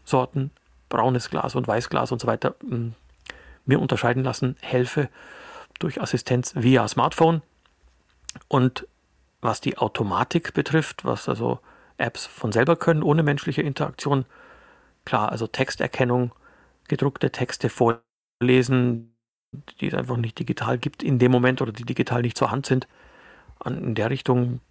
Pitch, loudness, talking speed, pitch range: 125 Hz, -24 LUFS, 140 wpm, 120-140 Hz